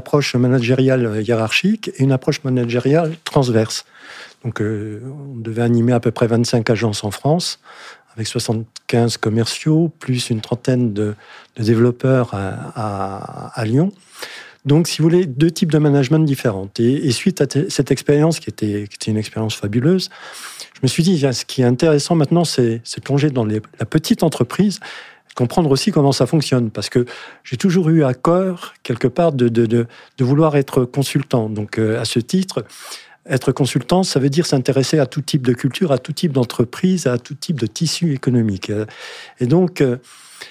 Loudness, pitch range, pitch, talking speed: -17 LUFS, 115-155 Hz, 130 Hz, 185 wpm